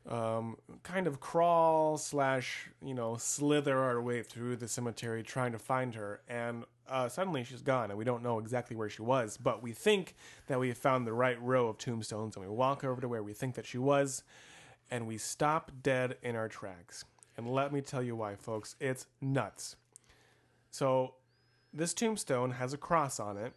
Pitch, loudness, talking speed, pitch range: 125 Hz, -35 LUFS, 195 wpm, 115-135 Hz